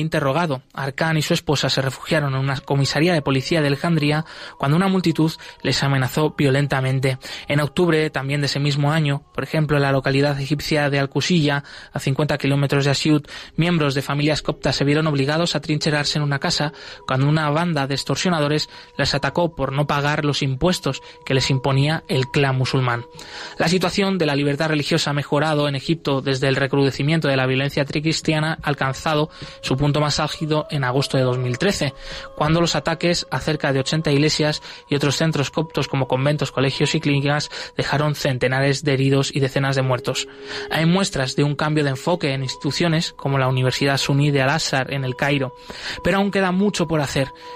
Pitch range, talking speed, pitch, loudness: 135-155 Hz, 185 wpm, 145 Hz, -20 LUFS